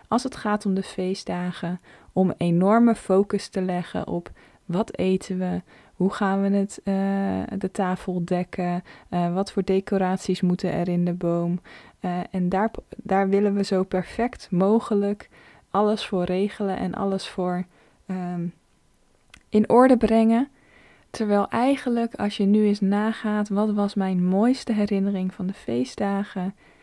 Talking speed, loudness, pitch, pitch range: 150 wpm, -24 LUFS, 195 Hz, 180-205 Hz